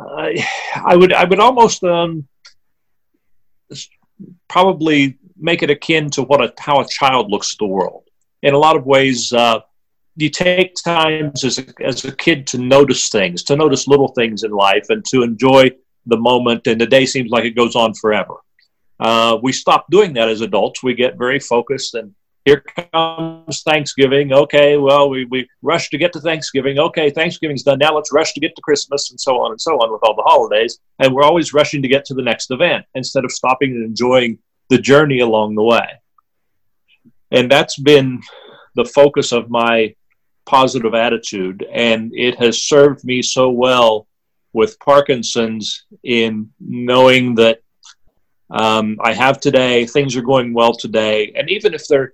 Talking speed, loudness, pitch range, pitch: 180 wpm, -14 LUFS, 120-150 Hz, 135 Hz